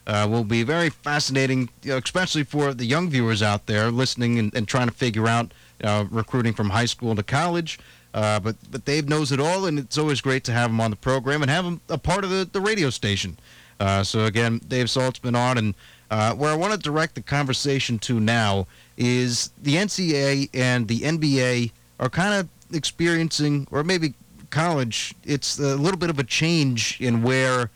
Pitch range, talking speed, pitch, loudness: 115-150 Hz, 210 wpm, 130 Hz, -23 LUFS